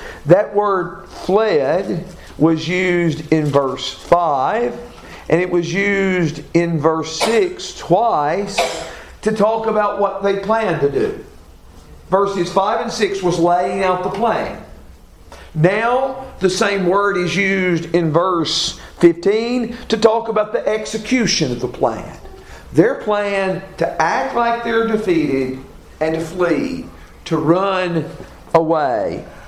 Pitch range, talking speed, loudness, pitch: 165-215 Hz, 130 wpm, -17 LUFS, 185 Hz